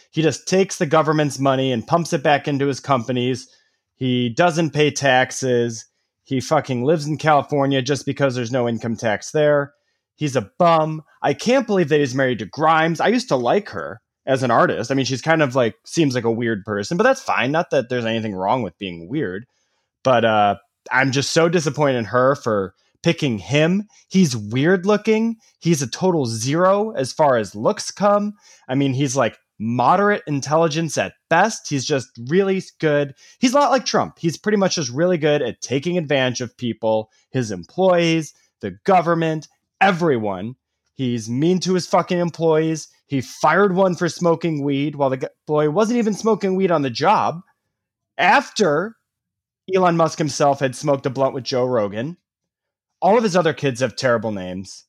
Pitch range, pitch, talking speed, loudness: 130-170 Hz, 145 Hz, 185 wpm, -19 LUFS